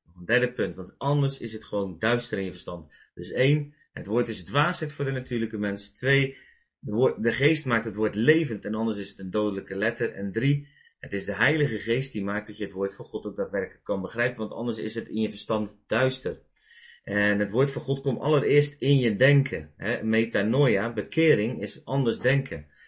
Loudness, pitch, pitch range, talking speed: -26 LUFS, 115 Hz, 105-135 Hz, 210 wpm